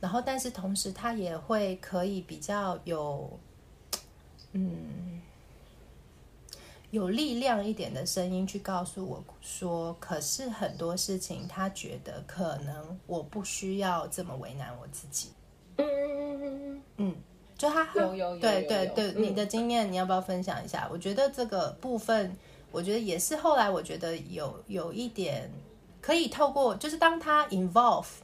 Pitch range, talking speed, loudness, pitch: 180-235 Hz, 230 characters per minute, -31 LUFS, 195 Hz